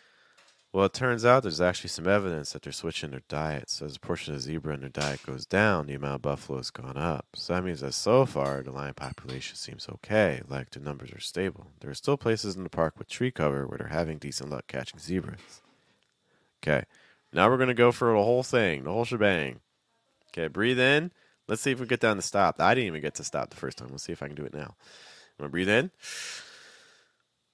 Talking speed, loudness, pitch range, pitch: 240 wpm, -28 LUFS, 70-115 Hz, 85 Hz